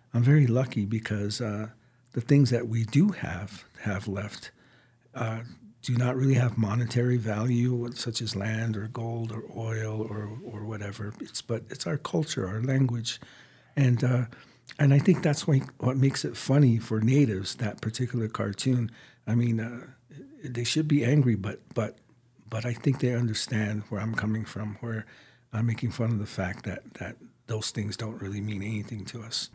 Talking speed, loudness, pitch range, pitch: 175 wpm, -28 LUFS, 110-125 Hz, 115 Hz